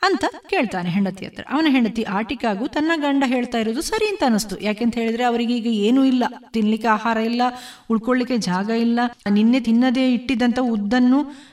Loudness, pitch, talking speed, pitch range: -20 LUFS, 240 Hz, 155 wpm, 225-265 Hz